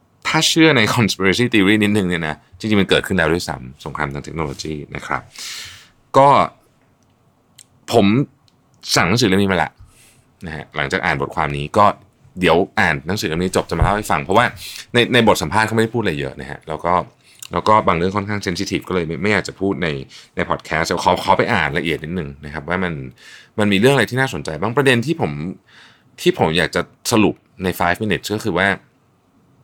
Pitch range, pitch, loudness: 80-110 Hz, 95 Hz, -17 LUFS